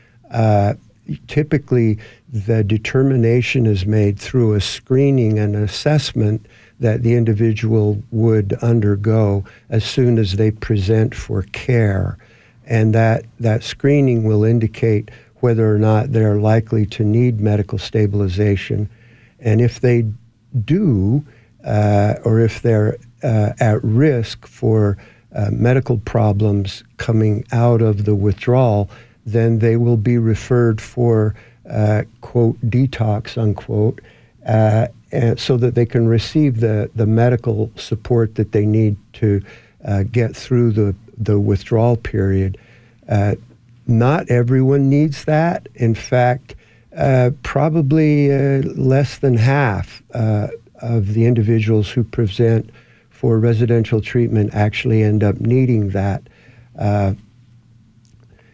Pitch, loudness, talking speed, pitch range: 115 Hz, -17 LUFS, 120 wpm, 105-120 Hz